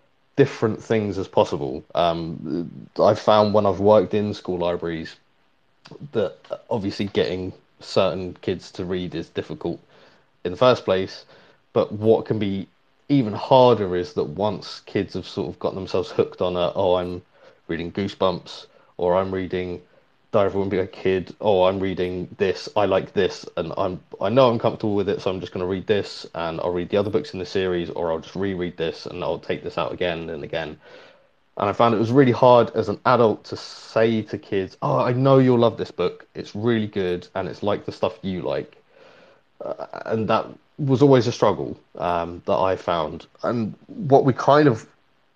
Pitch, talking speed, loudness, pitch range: 100 Hz, 195 wpm, -22 LUFS, 90-115 Hz